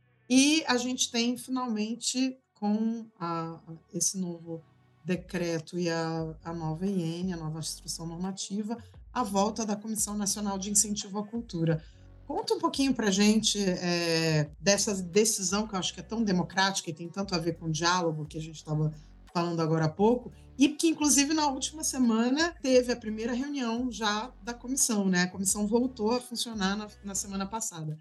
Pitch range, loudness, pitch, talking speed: 170-235 Hz, -29 LUFS, 200 Hz, 180 wpm